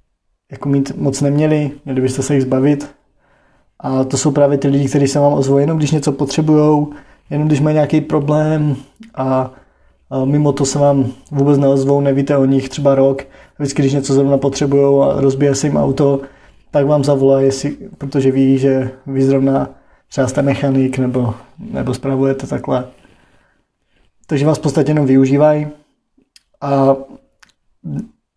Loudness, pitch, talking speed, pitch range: -15 LUFS, 140 Hz, 150 wpm, 135-145 Hz